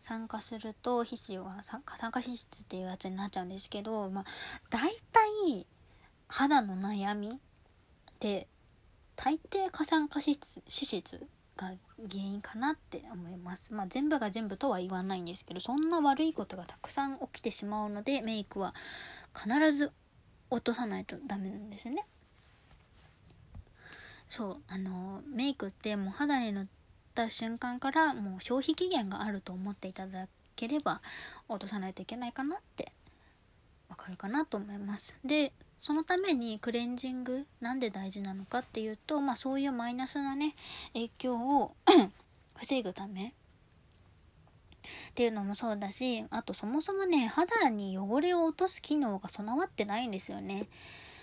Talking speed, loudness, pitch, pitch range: 255 characters per minute, -34 LUFS, 235 Hz, 200-280 Hz